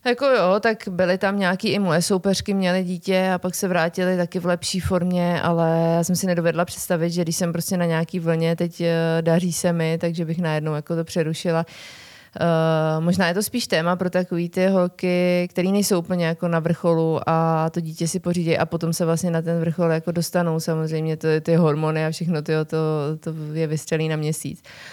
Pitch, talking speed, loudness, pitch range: 170 Hz, 205 wpm, -22 LUFS, 165-180 Hz